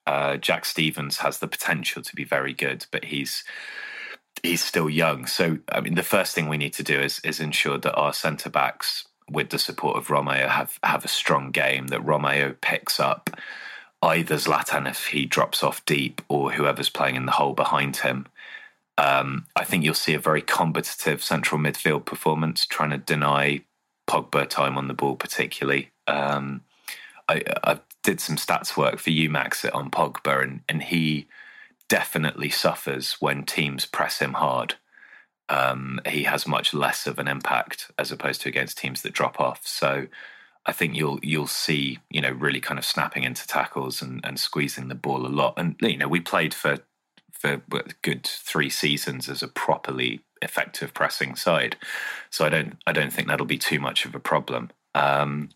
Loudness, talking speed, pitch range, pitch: -24 LUFS, 185 wpm, 65-75 Hz, 70 Hz